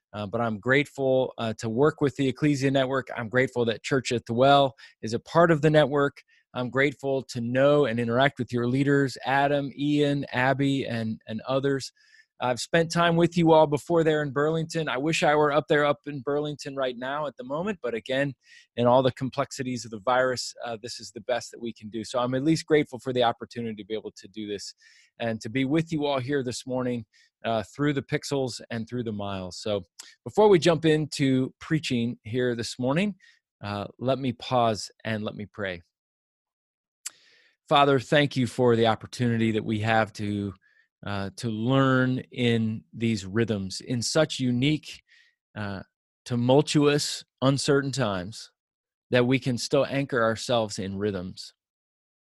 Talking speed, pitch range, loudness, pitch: 185 wpm, 115-145 Hz, -26 LUFS, 130 Hz